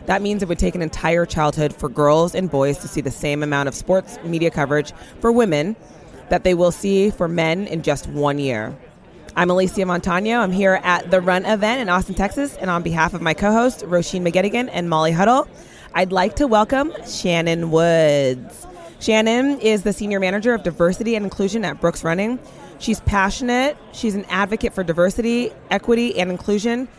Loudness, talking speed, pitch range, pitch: -19 LUFS, 190 wpm, 165-215 Hz, 185 Hz